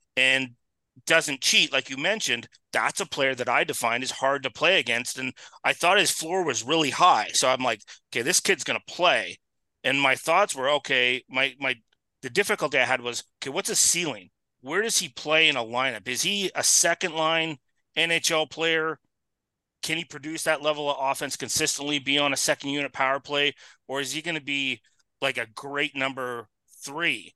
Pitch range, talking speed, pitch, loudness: 130-160 Hz, 195 wpm, 140 Hz, -24 LUFS